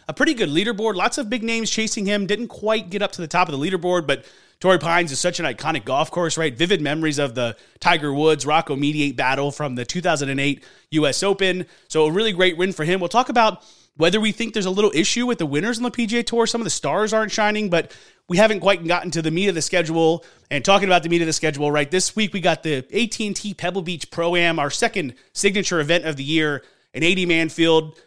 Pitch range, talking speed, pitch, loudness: 155-205 Hz, 245 wpm, 175 Hz, -20 LUFS